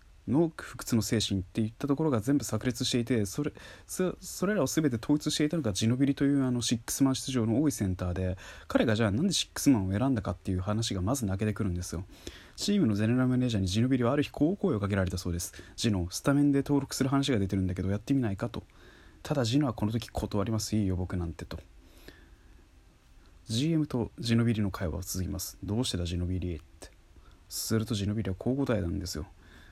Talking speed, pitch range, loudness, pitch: 465 characters per minute, 90-130 Hz, -30 LUFS, 105 Hz